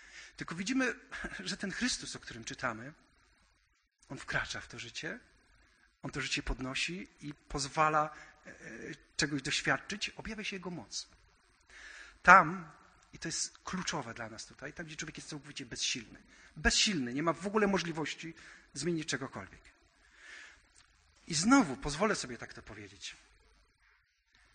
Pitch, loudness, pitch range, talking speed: 150 Hz, -33 LUFS, 125-175 Hz, 130 wpm